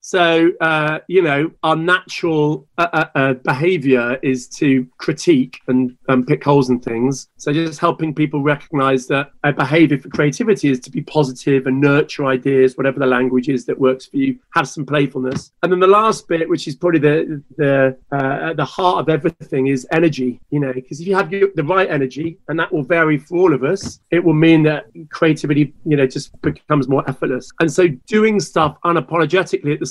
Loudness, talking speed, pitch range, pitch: -17 LUFS, 200 wpm, 135-170 Hz, 150 Hz